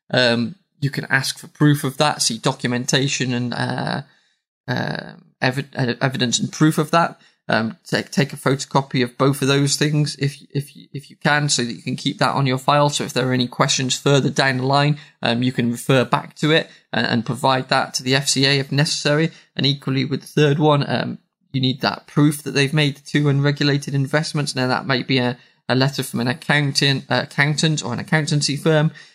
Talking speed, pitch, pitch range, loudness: 205 wpm, 140 Hz, 130-150 Hz, -19 LUFS